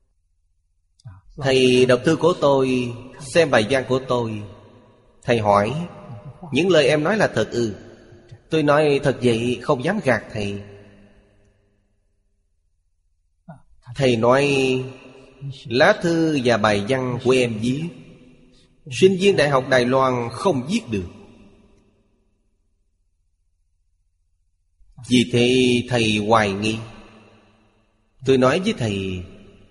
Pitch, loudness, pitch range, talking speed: 115 Hz, -19 LUFS, 100-130 Hz, 115 wpm